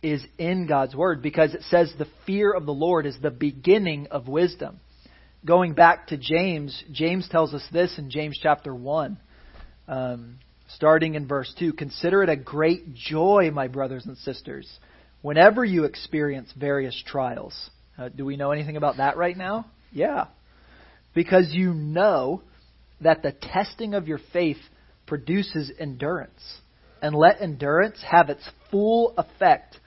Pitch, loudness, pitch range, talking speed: 155 Hz, -23 LUFS, 140-175 Hz, 155 wpm